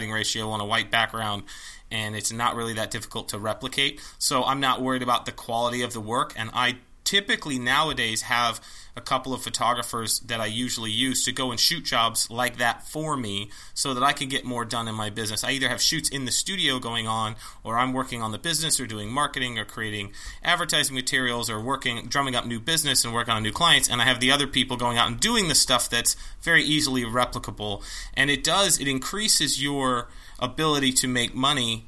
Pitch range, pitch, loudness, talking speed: 115-135 Hz, 125 Hz, -24 LUFS, 215 wpm